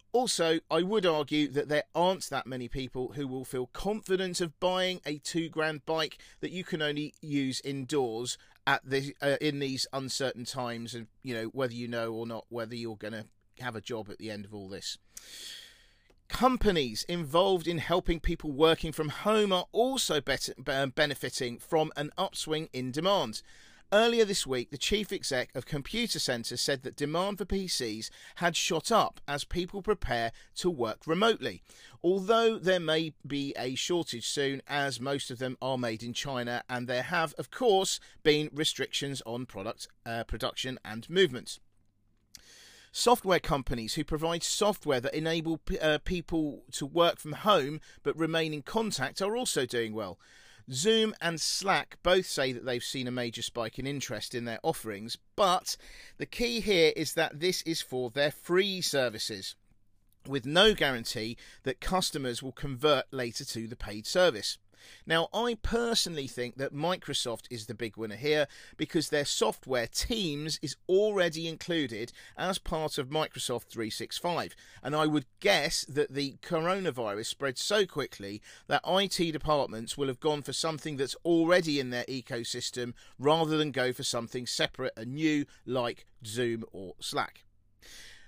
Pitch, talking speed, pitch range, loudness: 145 Hz, 165 wpm, 120-165 Hz, -31 LUFS